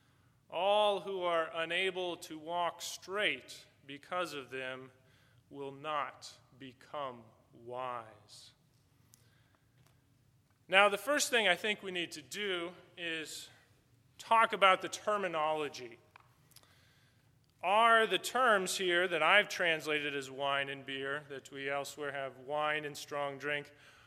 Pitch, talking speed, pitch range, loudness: 145 Hz, 120 wpm, 130-175 Hz, -33 LUFS